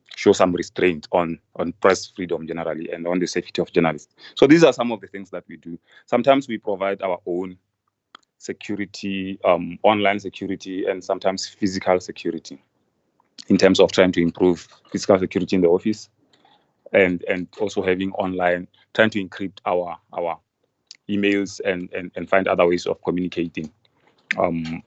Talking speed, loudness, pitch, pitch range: 165 wpm, -21 LUFS, 95 Hz, 90-100 Hz